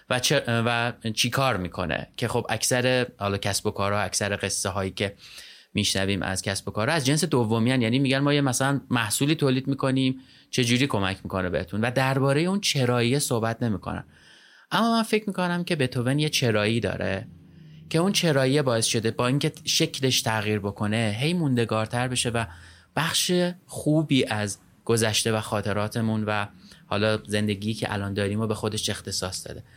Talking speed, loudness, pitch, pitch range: 170 wpm, -25 LUFS, 115 Hz, 105-135 Hz